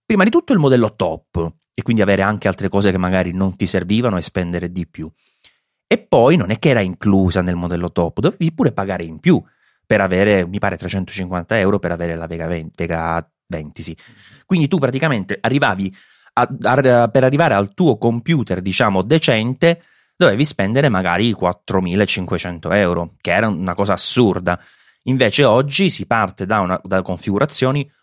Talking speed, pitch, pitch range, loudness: 175 wpm, 100 Hz, 90-125 Hz, -17 LUFS